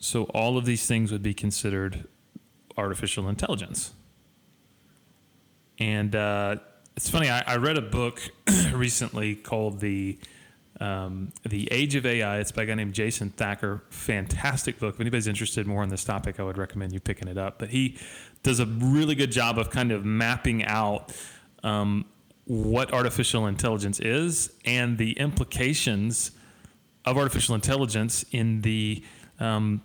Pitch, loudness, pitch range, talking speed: 110 Hz, -27 LUFS, 100-120 Hz, 155 wpm